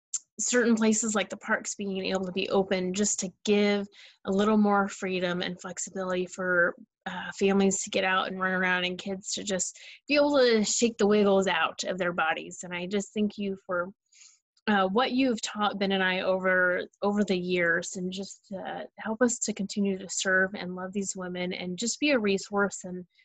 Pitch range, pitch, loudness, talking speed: 185-210 Hz, 195 Hz, -27 LUFS, 200 wpm